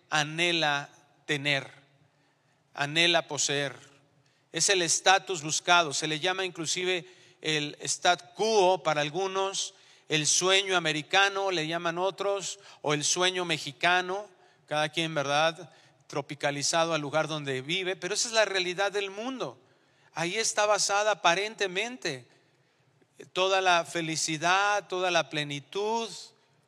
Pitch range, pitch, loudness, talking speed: 150-190 Hz, 170 Hz, -27 LUFS, 120 wpm